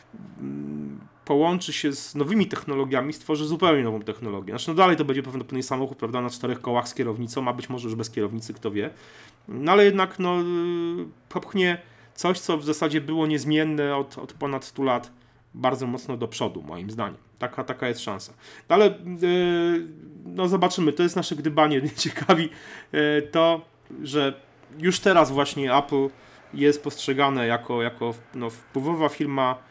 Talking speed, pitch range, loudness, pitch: 165 wpm, 125-165 Hz, -24 LUFS, 140 Hz